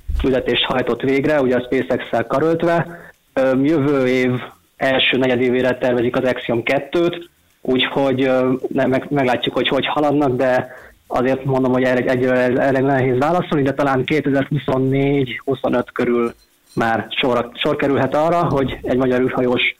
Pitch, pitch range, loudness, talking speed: 130 Hz, 125-140 Hz, -18 LUFS, 125 wpm